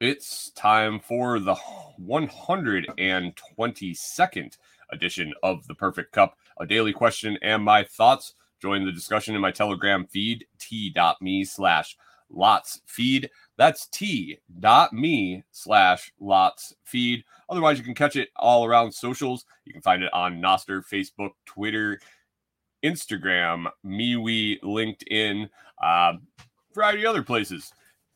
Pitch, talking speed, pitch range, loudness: 110 Hz, 125 wpm, 100-120 Hz, -23 LUFS